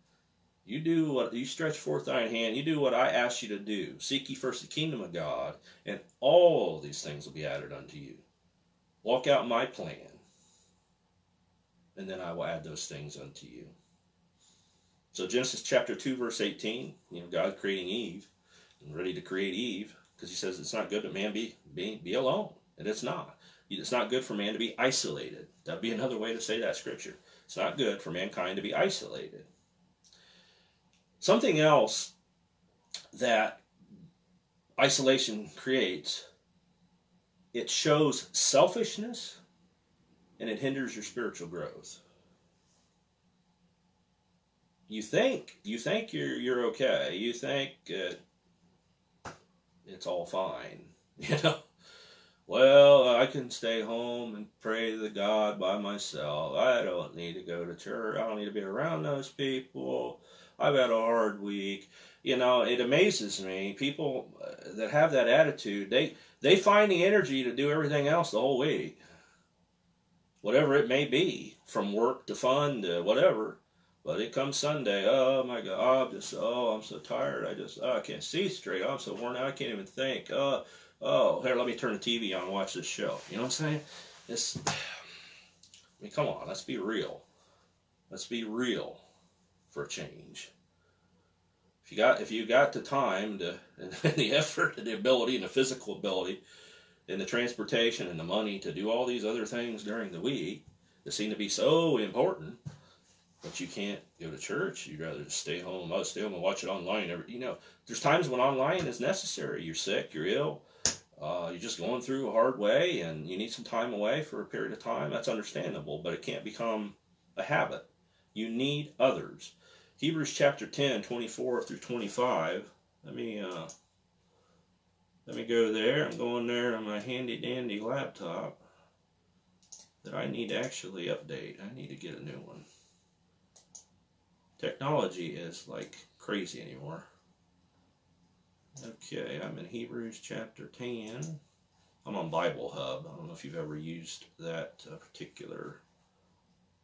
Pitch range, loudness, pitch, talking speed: 95-135 Hz, -31 LUFS, 115 Hz, 170 wpm